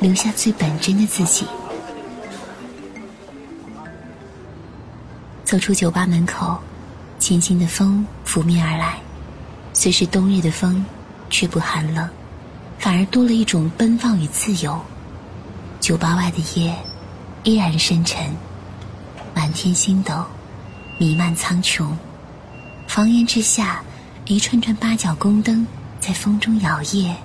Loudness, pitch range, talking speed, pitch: -18 LUFS, 155-200 Hz, 165 characters per minute, 175 Hz